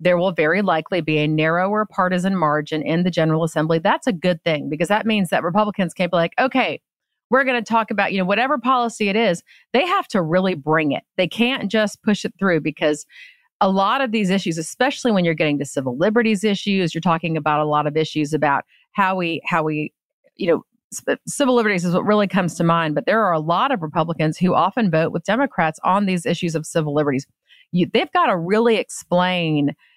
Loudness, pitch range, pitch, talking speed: -19 LUFS, 160-215 Hz, 180 Hz, 220 wpm